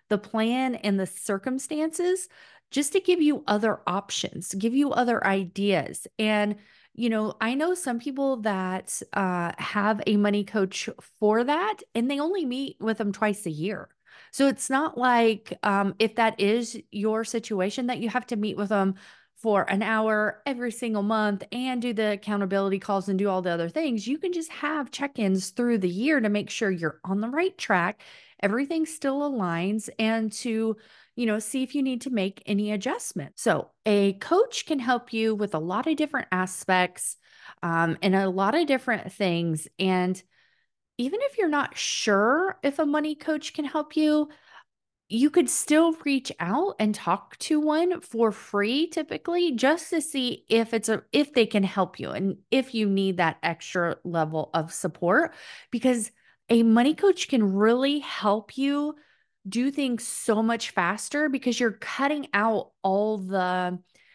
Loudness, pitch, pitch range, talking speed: -26 LUFS, 225 Hz, 200-275 Hz, 175 wpm